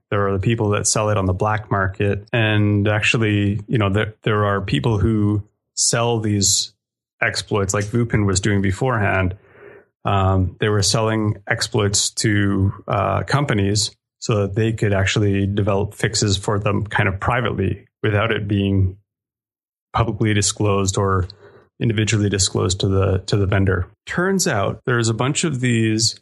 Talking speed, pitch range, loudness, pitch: 160 wpm, 100-115 Hz, -19 LUFS, 105 Hz